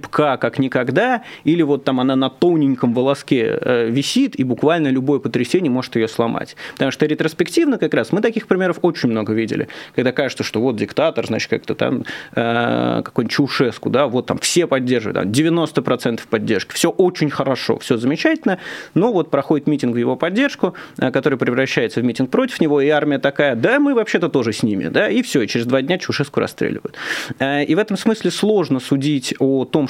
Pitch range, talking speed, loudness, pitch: 130-175 Hz, 190 wpm, -18 LUFS, 145 Hz